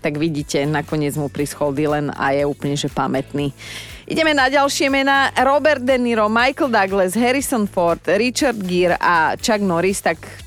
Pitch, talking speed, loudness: 180 Hz, 160 wpm, -18 LUFS